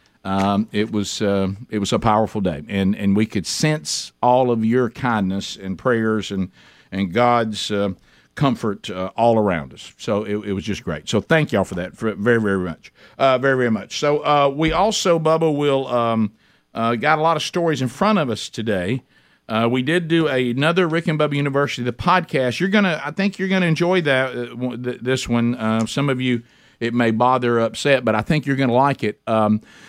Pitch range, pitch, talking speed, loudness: 105-145 Hz, 120 Hz, 210 wpm, -20 LUFS